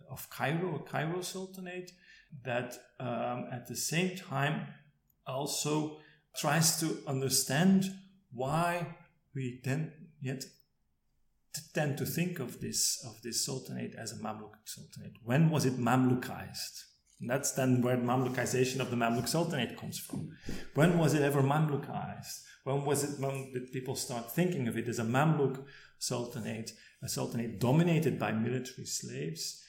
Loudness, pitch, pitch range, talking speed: -33 LUFS, 135 Hz, 120-155 Hz, 145 wpm